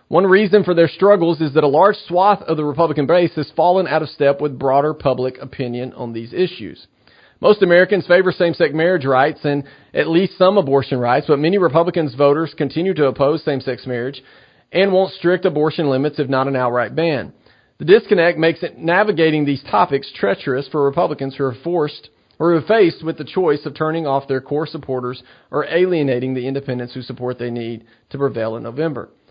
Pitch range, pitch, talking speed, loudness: 130-170 Hz, 150 Hz, 195 wpm, -17 LUFS